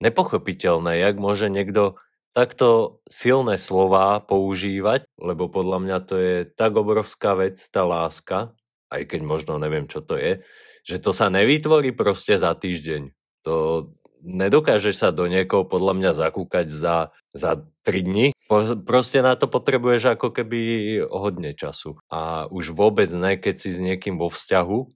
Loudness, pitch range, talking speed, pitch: -21 LUFS, 90-120 Hz, 150 wpm, 95 Hz